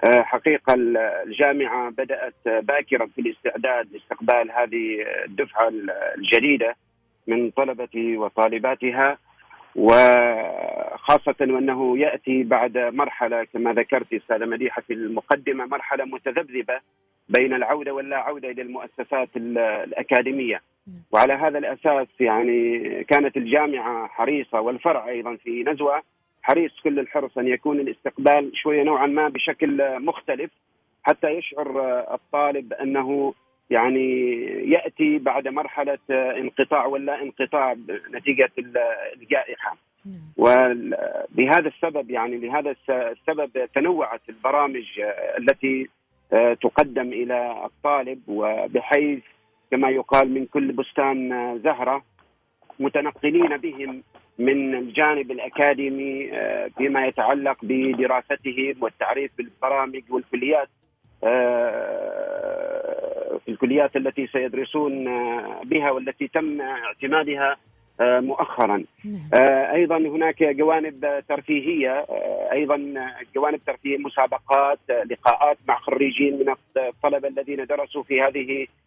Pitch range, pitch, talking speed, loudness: 125-150 Hz, 135 Hz, 95 wpm, -22 LUFS